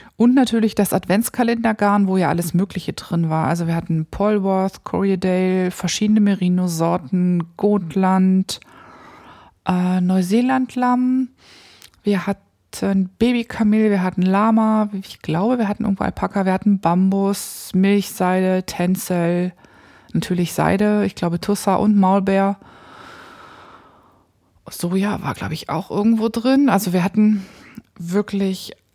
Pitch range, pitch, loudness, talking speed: 185-215 Hz, 195 Hz, -19 LUFS, 115 wpm